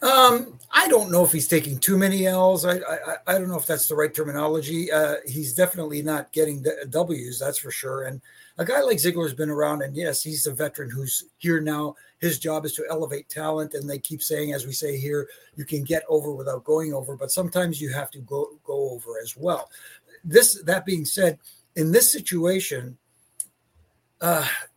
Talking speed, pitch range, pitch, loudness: 205 wpm, 145-175 Hz, 155 Hz, -23 LUFS